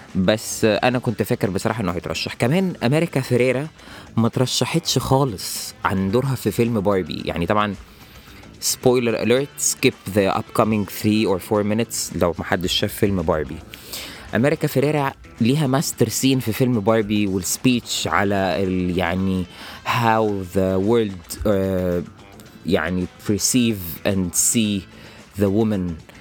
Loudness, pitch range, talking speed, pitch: -20 LUFS, 95-120 Hz, 130 wpm, 110 Hz